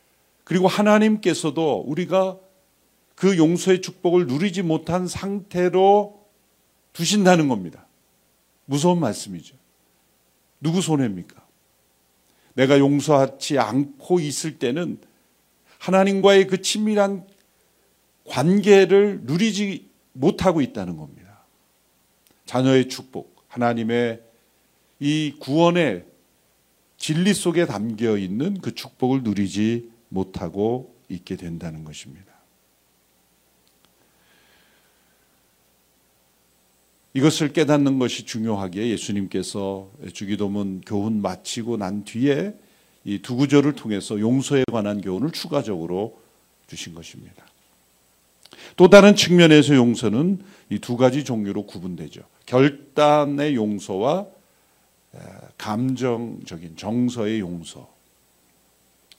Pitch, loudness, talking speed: 120 Hz, -20 LUFS, 220 characters per minute